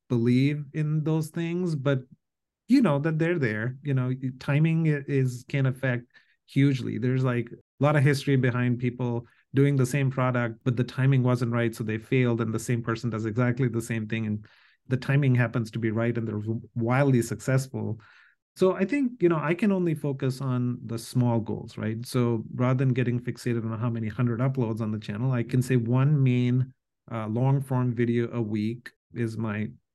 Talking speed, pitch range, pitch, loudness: 195 wpm, 115-135 Hz, 125 Hz, -26 LUFS